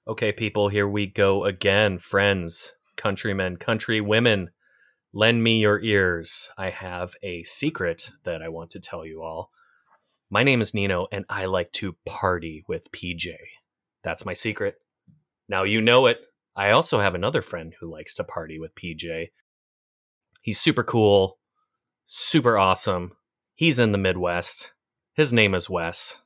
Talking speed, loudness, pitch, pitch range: 150 wpm, -23 LUFS, 100 Hz, 90-115 Hz